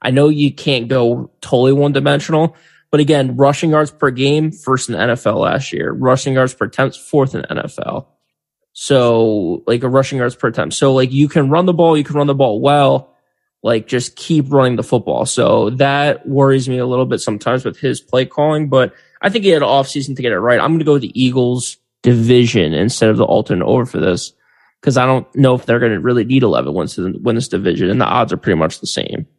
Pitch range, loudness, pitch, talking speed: 125-145 Hz, -14 LUFS, 135 Hz, 235 wpm